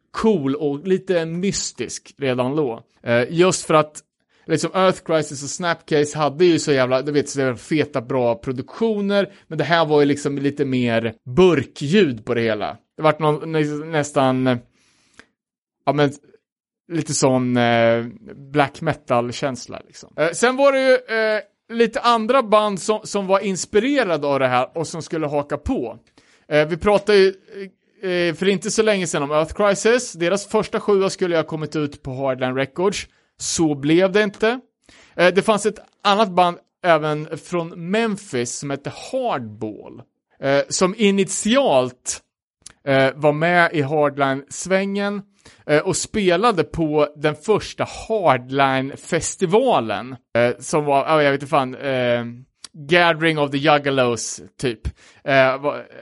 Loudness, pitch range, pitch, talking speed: -19 LUFS, 135-195 Hz, 155 Hz, 150 wpm